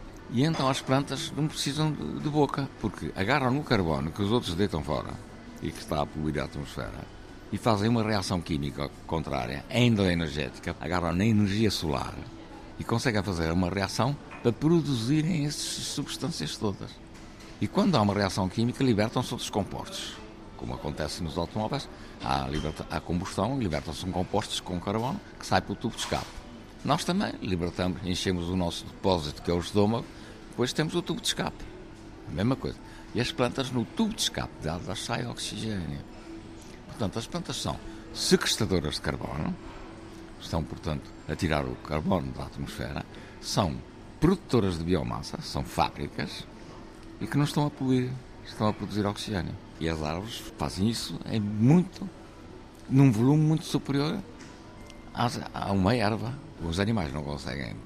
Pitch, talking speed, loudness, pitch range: 105 Hz, 160 wpm, -29 LUFS, 85-125 Hz